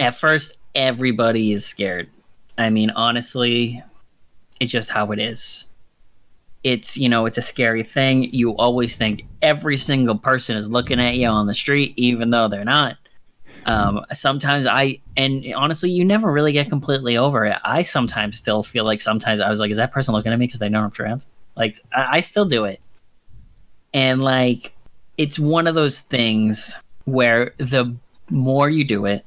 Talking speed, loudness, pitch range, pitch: 180 wpm, -19 LUFS, 110-135 Hz, 120 Hz